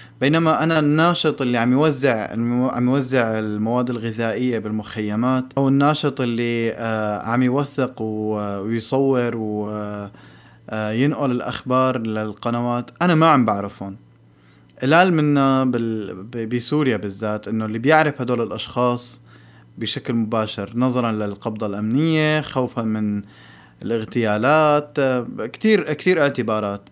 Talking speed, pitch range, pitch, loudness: 110 wpm, 110-135 Hz, 120 Hz, -20 LUFS